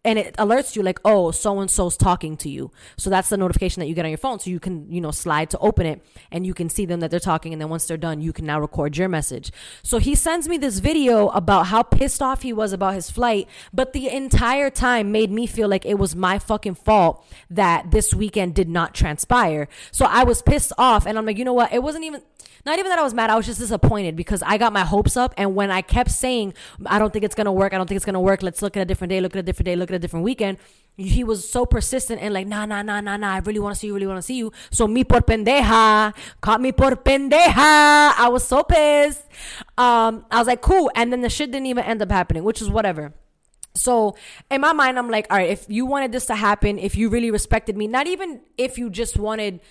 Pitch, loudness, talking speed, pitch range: 210 Hz, -19 LUFS, 270 wpm, 190-245 Hz